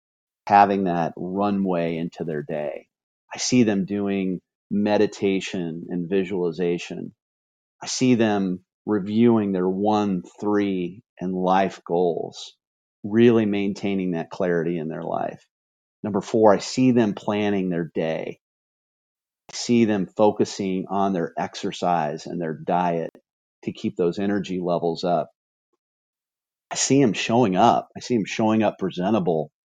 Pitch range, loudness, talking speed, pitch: 85-105 Hz, -23 LUFS, 130 wpm, 95 Hz